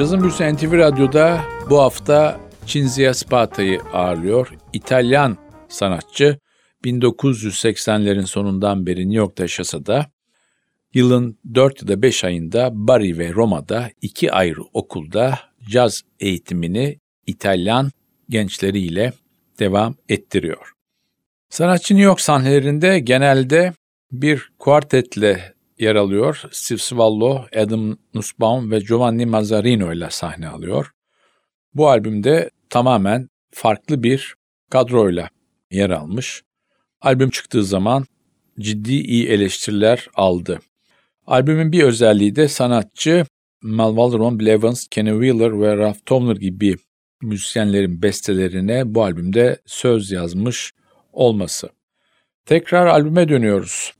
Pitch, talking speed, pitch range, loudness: 115 Hz, 105 wpm, 105-135 Hz, -17 LUFS